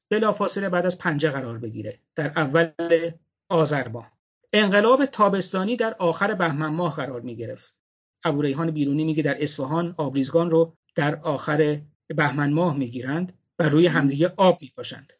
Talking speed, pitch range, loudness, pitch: 135 wpm, 145-175 Hz, -23 LUFS, 160 Hz